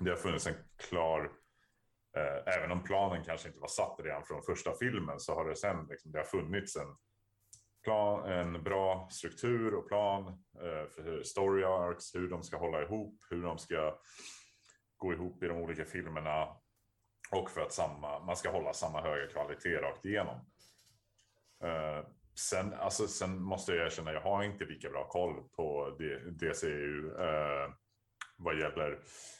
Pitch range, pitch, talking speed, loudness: 80-100 Hz, 90 Hz, 165 wpm, -37 LUFS